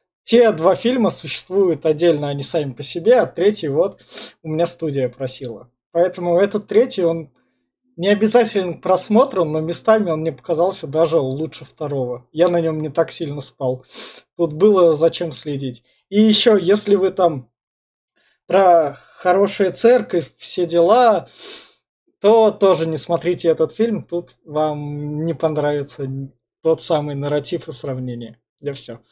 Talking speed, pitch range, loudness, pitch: 145 wpm, 145-185 Hz, -18 LUFS, 165 Hz